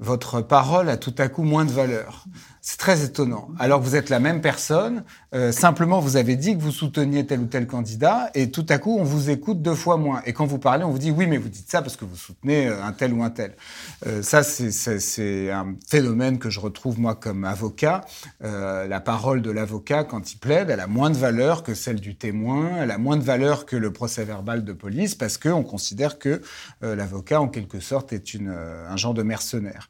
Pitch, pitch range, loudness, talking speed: 125 Hz, 110-150 Hz, -23 LUFS, 240 wpm